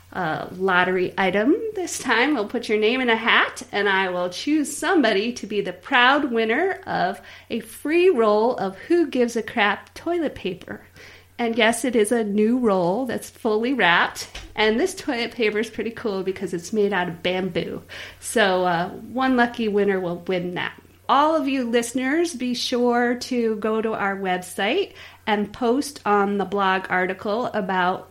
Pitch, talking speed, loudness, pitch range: 225 Hz, 175 wpm, -22 LUFS, 195-255 Hz